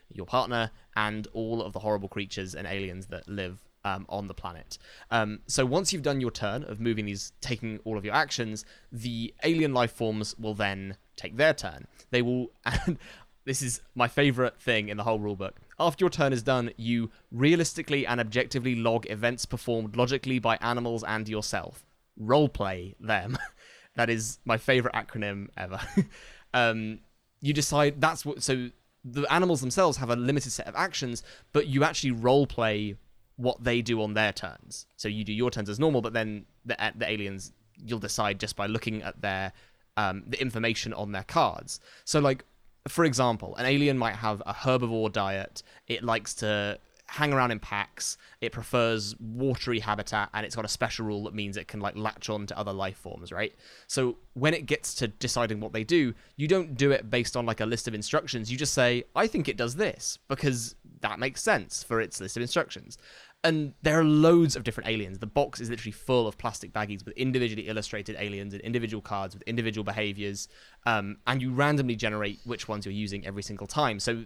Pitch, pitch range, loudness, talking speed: 115 Hz, 105-130 Hz, -29 LUFS, 200 wpm